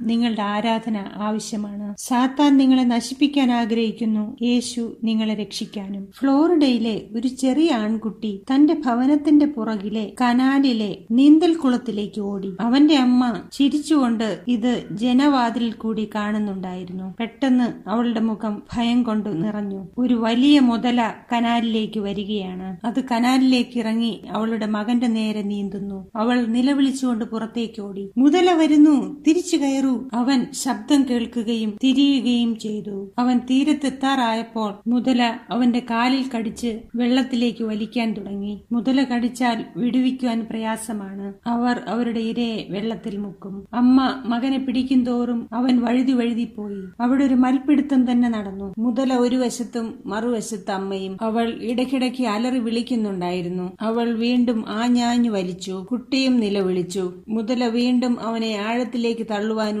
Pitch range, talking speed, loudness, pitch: 215-250 Hz, 110 wpm, -21 LUFS, 235 Hz